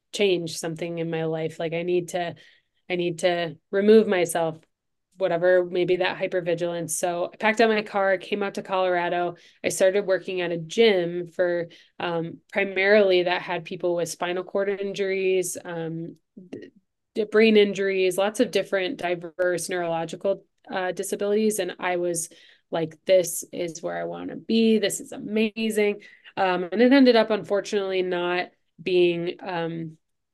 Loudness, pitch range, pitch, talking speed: -24 LUFS, 175-200 Hz, 185 Hz, 150 wpm